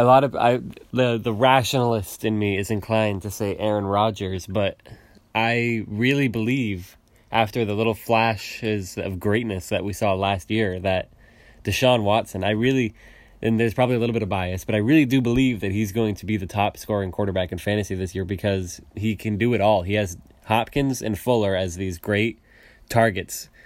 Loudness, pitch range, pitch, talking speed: -23 LUFS, 100-115 Hz, 110 Hz, 195 wpm